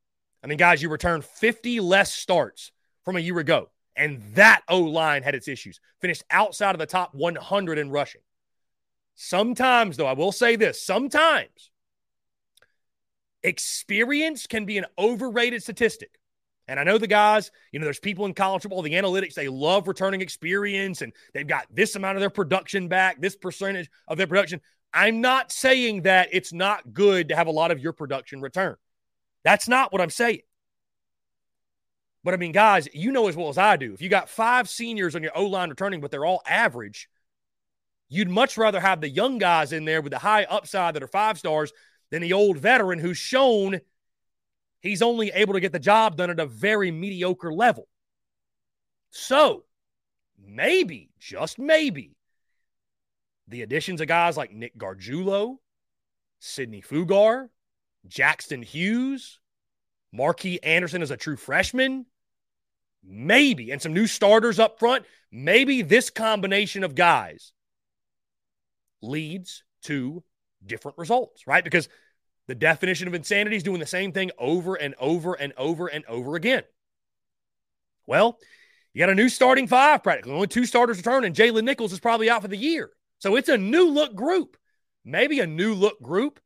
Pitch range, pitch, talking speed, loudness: 165-230 Hz, 195 Hz, 165 wpm, -22 LUFS